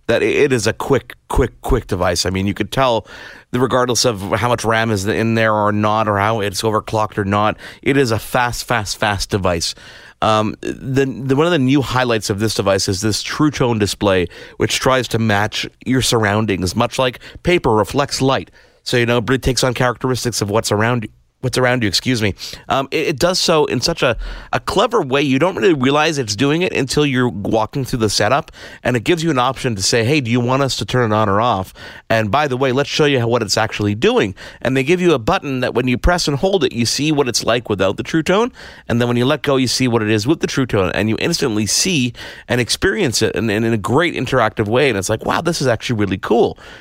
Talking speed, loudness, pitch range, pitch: 250 wpm, -17 LUFS, 110-135 Hz, 120 Hz